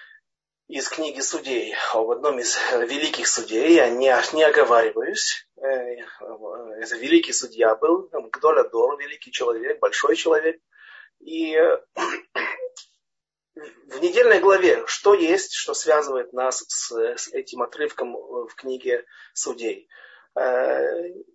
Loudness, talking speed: -21 LUFS, 125 wpm